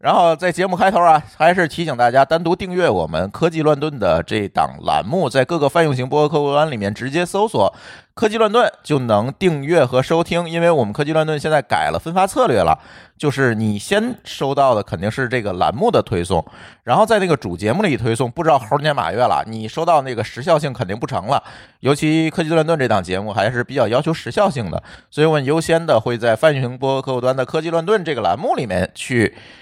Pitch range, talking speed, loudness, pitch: 125-165 Hz, 350 characters per minute, -17 LUFS, 150 Hz